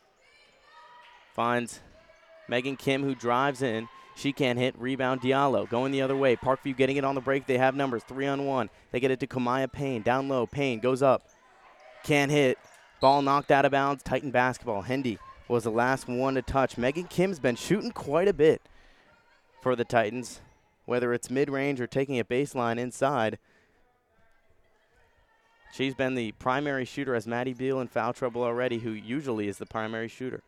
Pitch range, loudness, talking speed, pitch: 120-140 Hz, -28 LUFS, 180 wpm, 130 Hz